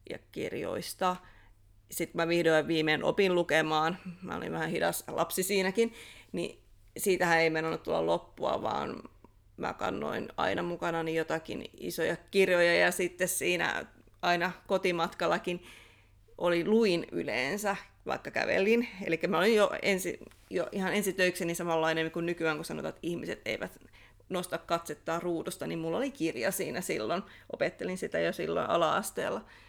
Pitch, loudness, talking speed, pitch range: 175 Hz, -31 LUFS, 135 wpm, 160-190 Hz